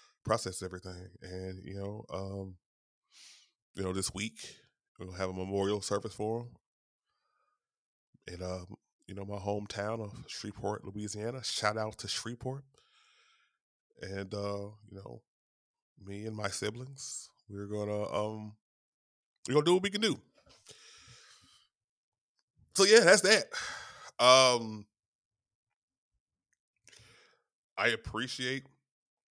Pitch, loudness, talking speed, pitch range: 105 Hz, -31 LUFS, 120 wpm, 100-115 Hz